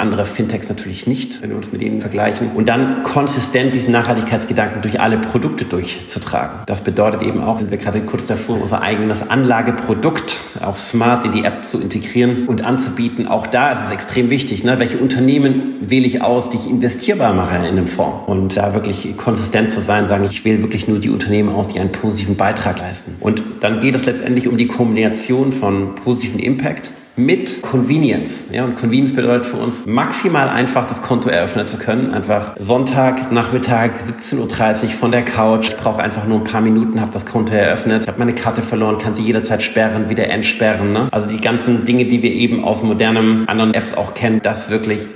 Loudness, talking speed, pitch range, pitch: -16 LUFS, 195 wpm, 105-125 Hz, 115 Hz